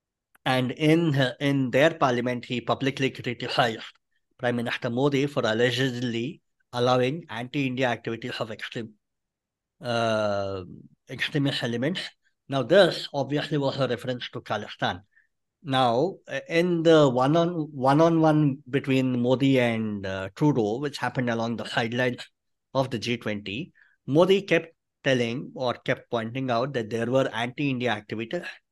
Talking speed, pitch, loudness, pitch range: 130 wpm, 130 Hz, -25 LUFS, 120-140 Hz